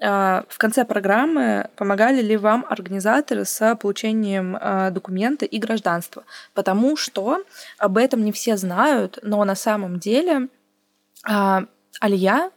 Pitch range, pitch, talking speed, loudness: 195-245 Hz, 215 Hz, 115 wpm, -20 LUFS